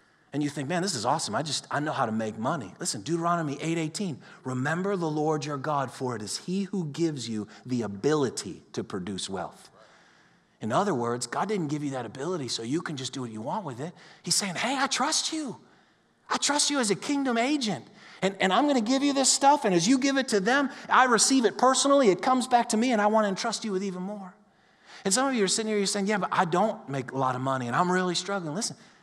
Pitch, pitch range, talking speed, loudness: 190 Hz, 145-235 Hz, 255 wpm, -27 LUFS